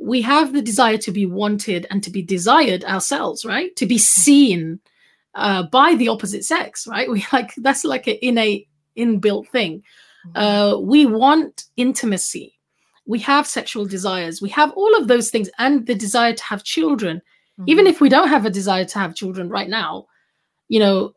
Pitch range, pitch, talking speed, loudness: 200-270 Hz, 225 Hz, 180 wpm, -17 LUFS